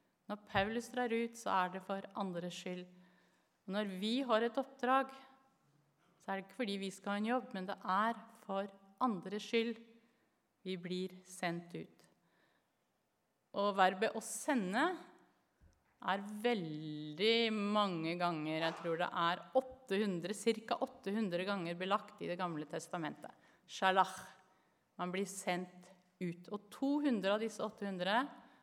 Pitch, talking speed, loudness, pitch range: 200 Hz, 140 wpm, -38 LUFS, 180-230 Hz